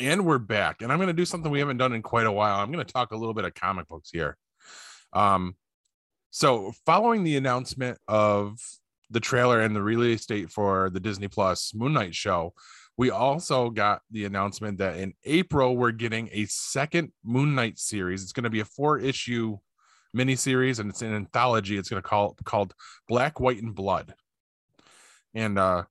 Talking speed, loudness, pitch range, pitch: 195 wpm, -26 LUFS, 105-130 Hz, 115 Hz